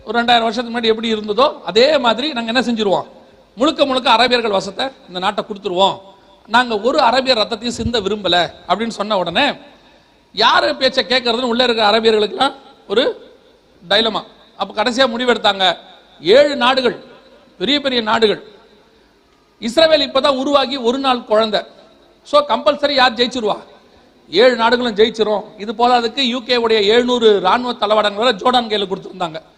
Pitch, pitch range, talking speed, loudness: 235 Hz, 215-260 Hz, 130 wpm, -15 LUFS